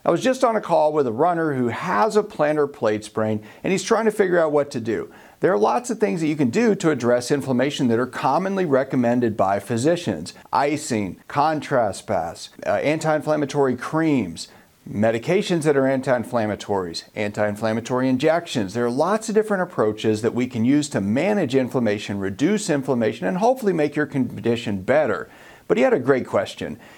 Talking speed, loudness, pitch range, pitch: 185 wpm, -21 LUFS, 115-170 Hz, 140 Hz